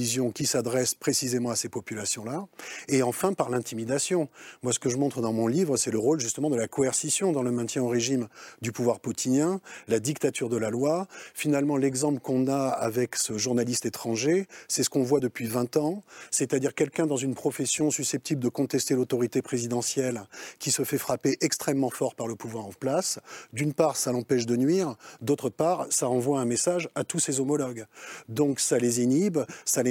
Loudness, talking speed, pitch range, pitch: -27 LUFS, 195 wpm, 120-145 Hz, 130 Hz